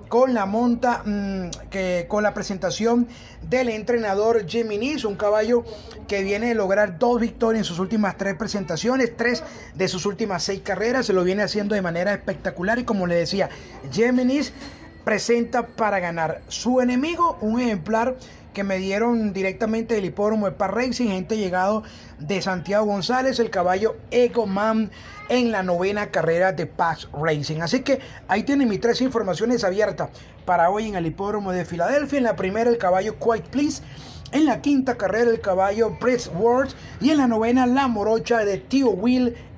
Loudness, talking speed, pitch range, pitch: -22 LUFS, 170 wpm, 190-240 Hz, 215 Hz